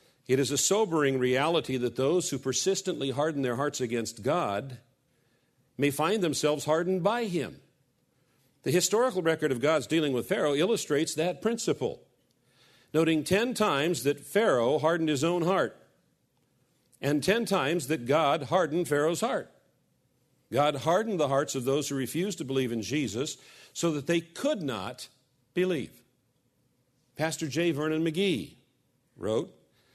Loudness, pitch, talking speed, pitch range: -28 LUFS, 155 Hz, 140 wpm, 135-175 Hz